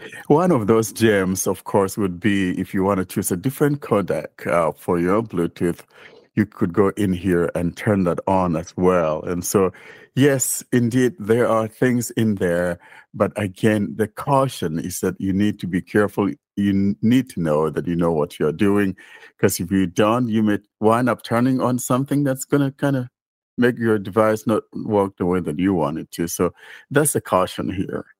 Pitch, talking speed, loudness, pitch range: 105 Hz, 200 wpm, -20 LUFS, 95-120 Hz